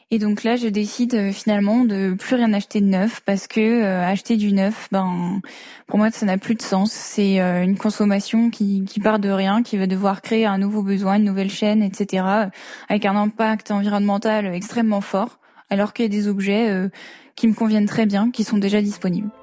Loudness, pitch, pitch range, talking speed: -20 LUFS, 205 Hz, 195-220 Hz, 210 wpm